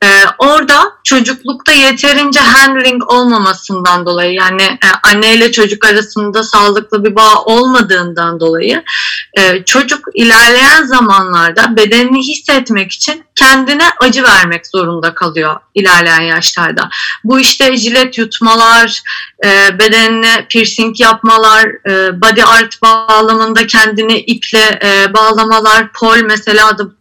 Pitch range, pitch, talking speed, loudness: 200-245 Hz, 225 Hz, 110 wpm, -6 LUFS